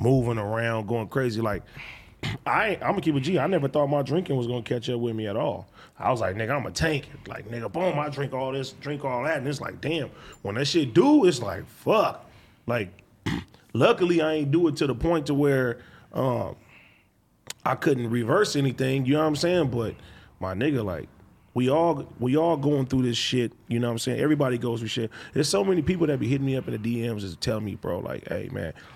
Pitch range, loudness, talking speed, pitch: 120-150 Hz, -26 LUFS, 230 wpm, 135 Hz